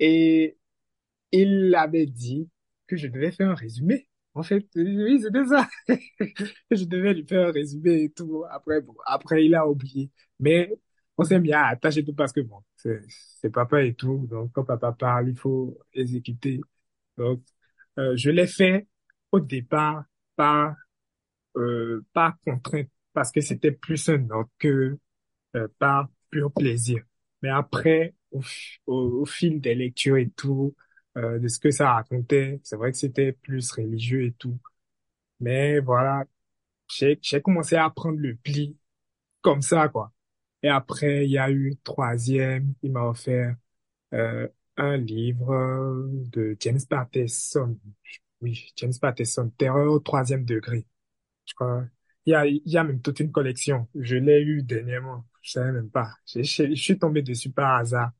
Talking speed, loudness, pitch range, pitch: 160 wpm, -24 LUFS, 125-155 Hz, 135 Hz